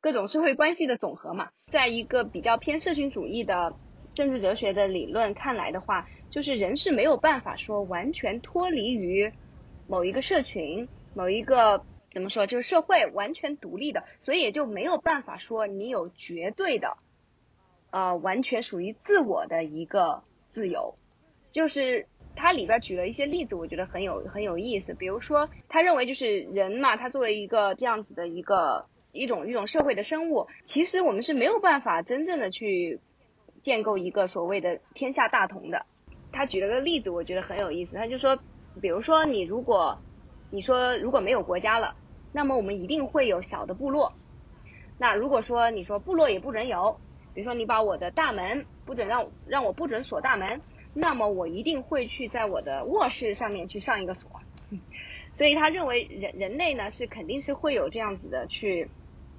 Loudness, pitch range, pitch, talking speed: -27 LUFS, 200-310 Hz, 245 Hz, 285 characters per minute